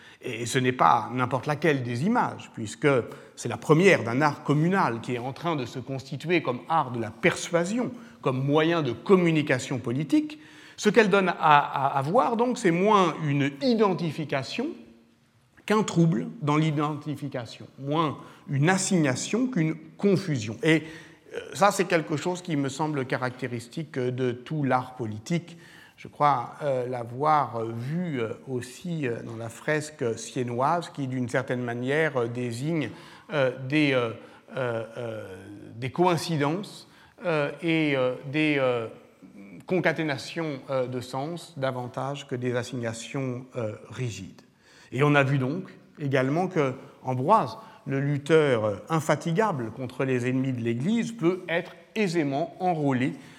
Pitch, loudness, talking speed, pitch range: 145 Hz, -26 LUFS, 140 wpm, 125-165 Hz